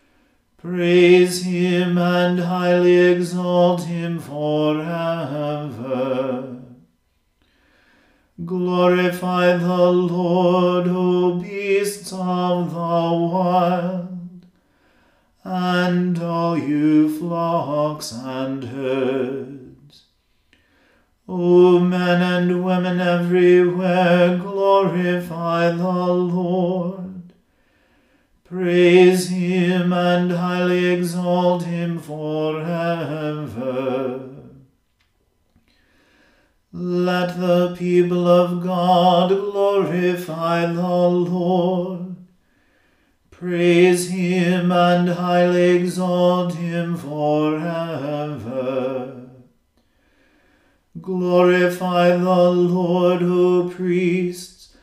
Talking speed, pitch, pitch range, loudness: 60 wpm, 180 Hz, 165-180 Hz, -19 LUFS